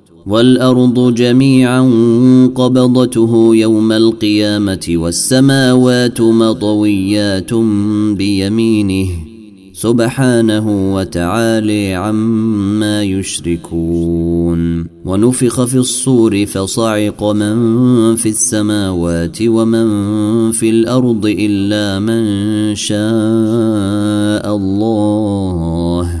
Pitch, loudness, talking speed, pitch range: 105 Hz, -12 LUFS, 60 wpm, 100-115 Hz